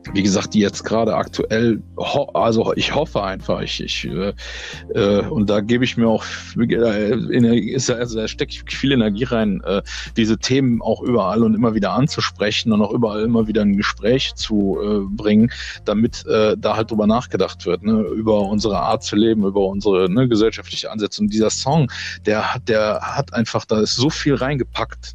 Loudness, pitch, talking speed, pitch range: -19 LUFS, 110 Hz, 180 wpm, 100-115 Hz